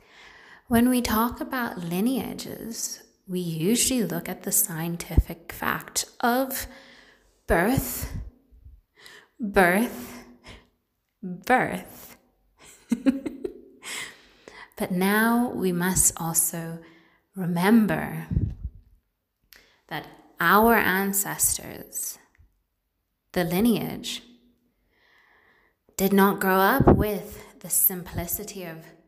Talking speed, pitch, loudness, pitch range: 70 wpm, 195 Hz, -24 LUFS, 170-235 Hz